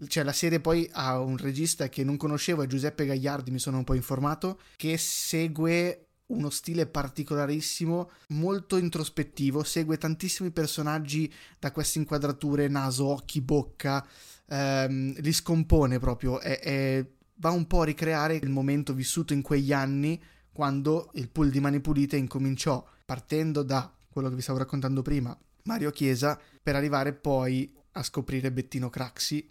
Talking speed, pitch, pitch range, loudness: 155 wpm, 145 Hz, 135-160 Hz, -29 LUFS